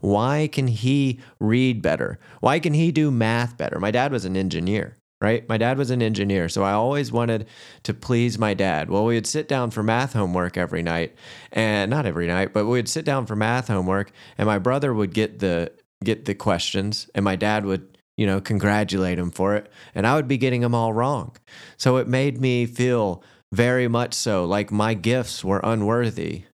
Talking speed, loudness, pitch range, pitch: 210 wpm, -22 LUFS, 100-125 Hz, 110 Hz